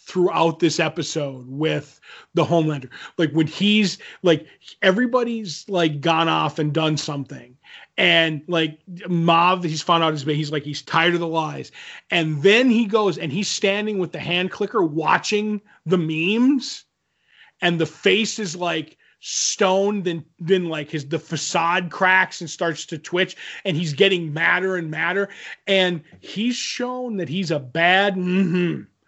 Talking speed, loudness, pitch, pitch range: 160 wpm, -21 LUFS, 170 Hz, 160-195 Hz